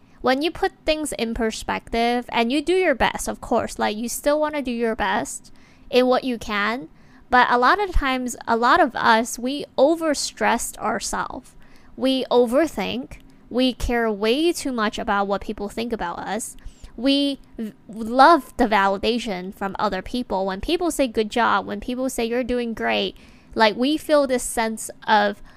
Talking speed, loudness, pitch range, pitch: 175 wpm, -21 LUFS, 220-275 Hz, 245 Hz